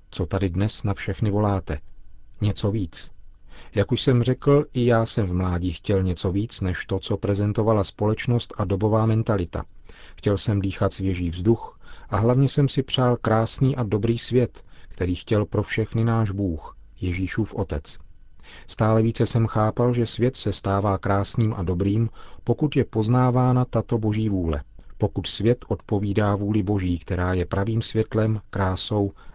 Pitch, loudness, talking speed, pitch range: 105 Hz, -23 LUFS, 155 wpm, 95-115 Hz